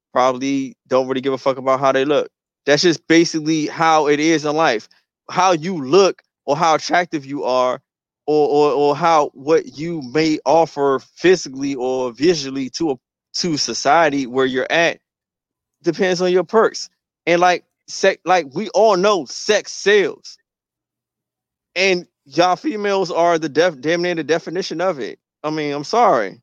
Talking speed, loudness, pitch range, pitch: 165 wpm, -17 LUFS, 140-185 Hz, 160 Hz